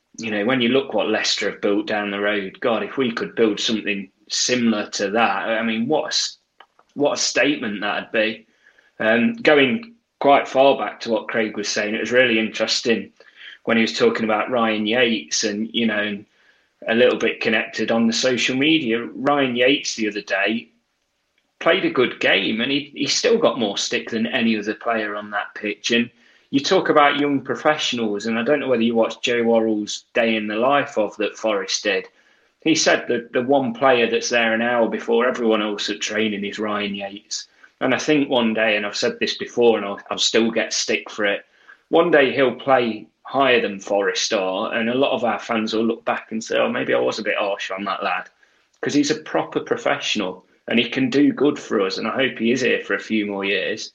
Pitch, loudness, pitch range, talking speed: 115 Hz, -20 LUFS, 105-130 Hz, 220 wpm